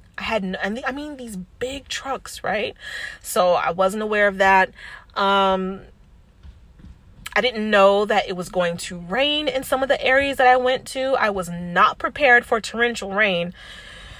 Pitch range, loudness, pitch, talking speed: 190-260 Hz, -20 LUFS, 215 Hz, 175 wpm